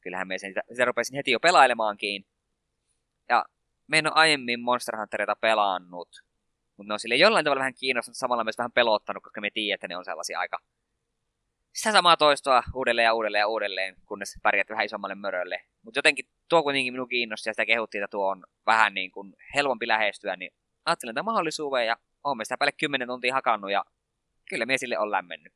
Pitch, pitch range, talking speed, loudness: 115 Hz, 105-130 Hz, 195 wpm, -25 LUFS